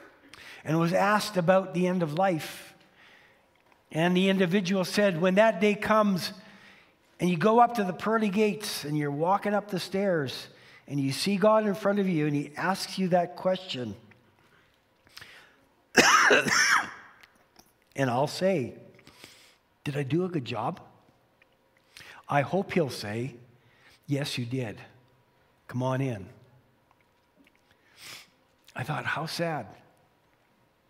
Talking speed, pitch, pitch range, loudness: 130 wpm, 175 Hz, 135-195 Hz, -26 LUFS